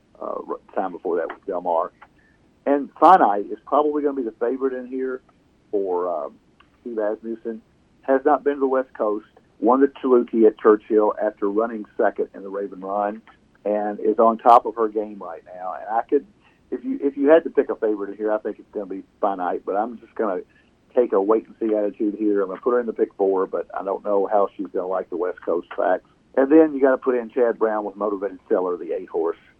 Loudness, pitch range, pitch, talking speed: -22 LUFS, 105-140 Hz, 115 Hz, 240 wpm